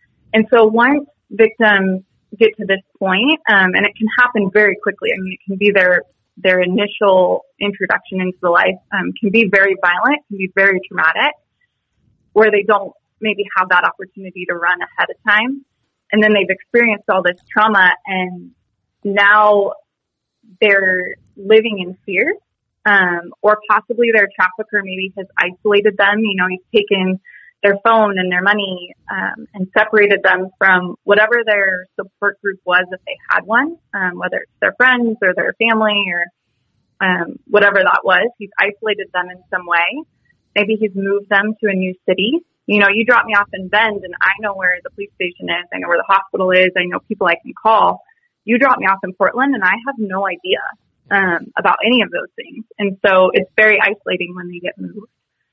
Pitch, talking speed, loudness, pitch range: 200 Hz, 190 wpm, -14 LUFS, 185-220 Hz